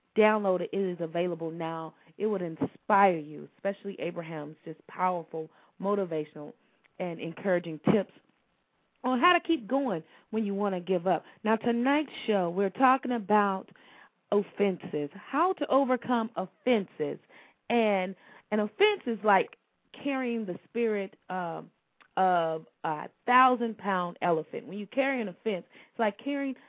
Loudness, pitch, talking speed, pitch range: -29 LUFS, 200 Hz, 140 wpm, 175-235 Hz